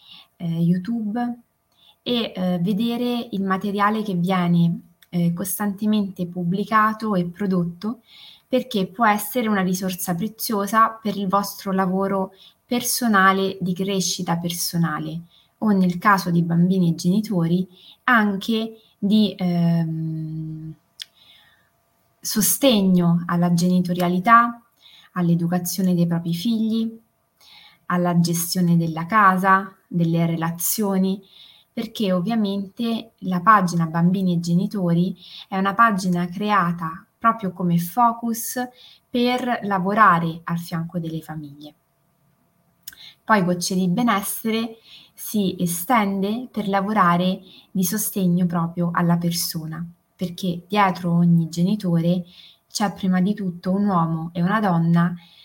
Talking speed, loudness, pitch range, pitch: 105 wpm, -21 LUFS, 170-210 Hz, 185 Hz